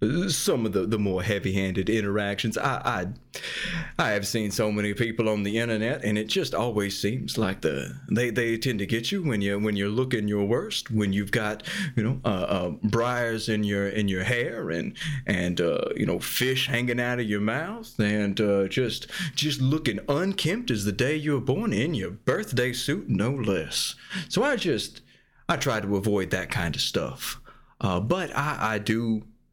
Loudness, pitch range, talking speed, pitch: -26 LUFS, 105-130 Hz, 195 wpm, 115 Hz